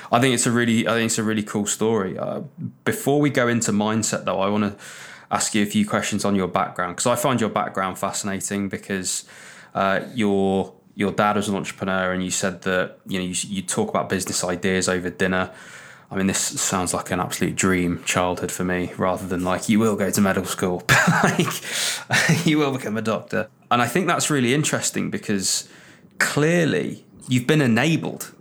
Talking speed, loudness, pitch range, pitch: 205 wpm, -22 LUFS, 95-120 Hz, 105 Hz